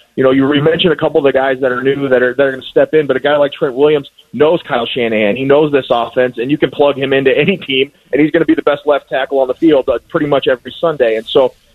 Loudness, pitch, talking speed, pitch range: -13 LUFS, 140 Hz, 300 wpm, 130-155 Hz